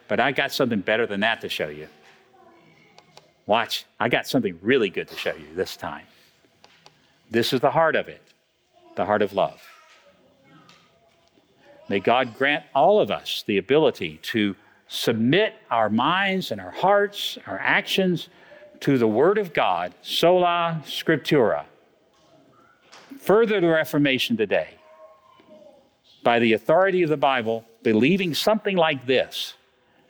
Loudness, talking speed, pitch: -22 LUFS, 140 wpm, 160 Hz